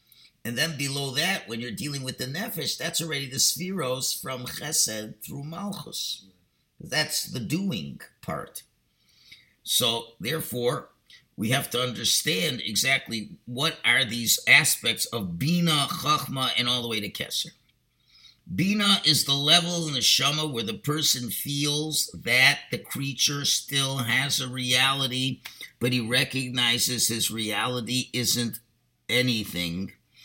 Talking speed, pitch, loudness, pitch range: 135 wpm, 130 Hz, -24 LUFS, 120-150 Hz